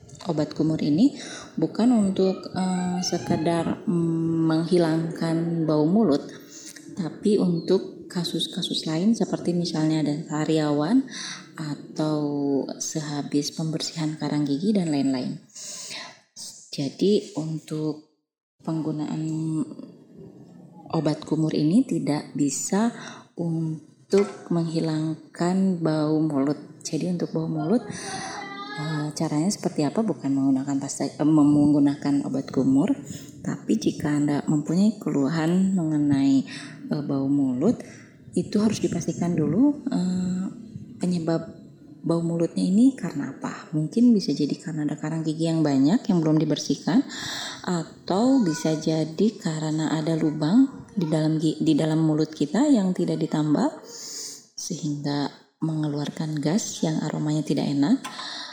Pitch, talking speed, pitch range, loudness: 160 Hz, 110 wpm, 150-185 Hz, -24 LUFS